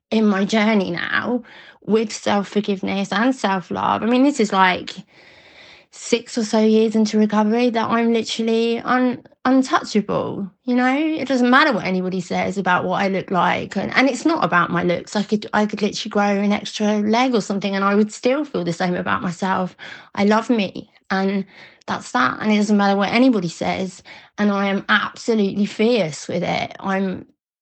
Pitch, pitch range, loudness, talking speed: 210 Hz, 195-230 Hz, -19 LUFS, 185 wpm